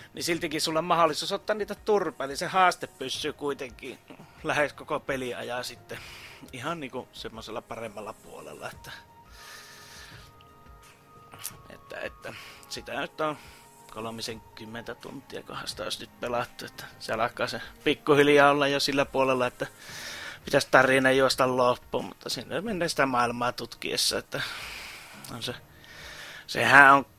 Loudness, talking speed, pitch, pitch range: -26 LUFS, 130 wpm, 135 Hz, 125-155 Hz